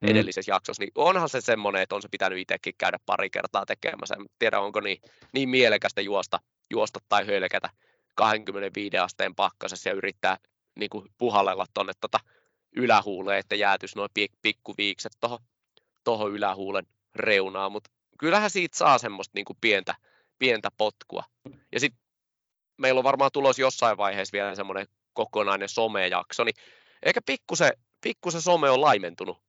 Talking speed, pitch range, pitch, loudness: 150 wpm, 100-135 Hz, 110 Hz, -26 LUFS